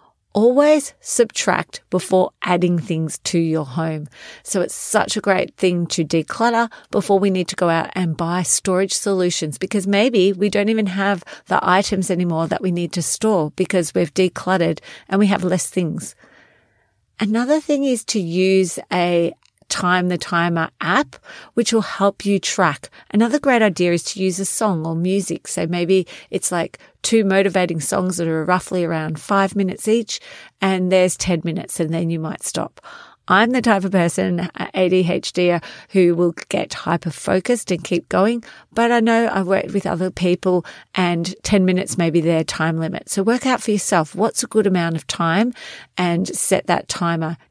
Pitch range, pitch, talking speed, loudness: 170-205 Hz, 185 Hz, 175 wpm, -19 LUFS